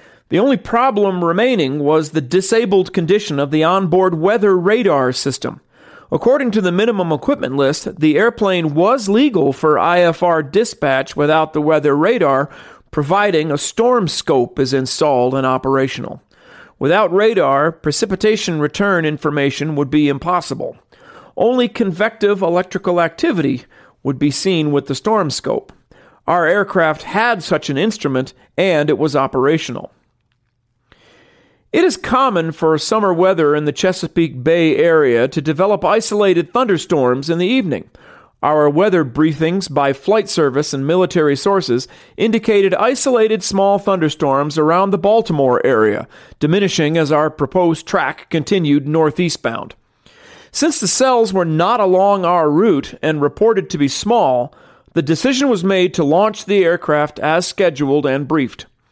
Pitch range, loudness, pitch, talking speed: 150-205 Hz, -15 LUFS, 170 Hz, 135 wpm